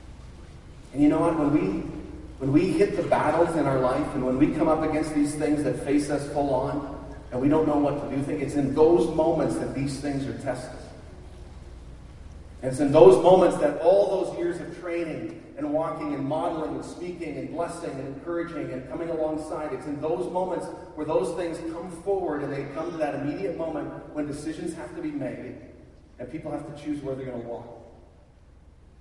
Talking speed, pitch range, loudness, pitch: 205 wpm, 135-165 Hz, -25 LUFS, 150 Hz